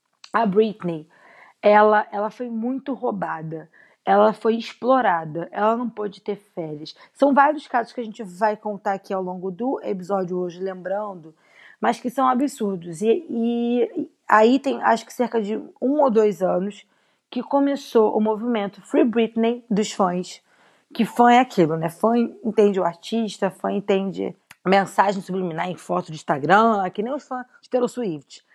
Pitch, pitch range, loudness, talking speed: 215 Hz, 190-245 Hz, -22 LUFS, 165 wpm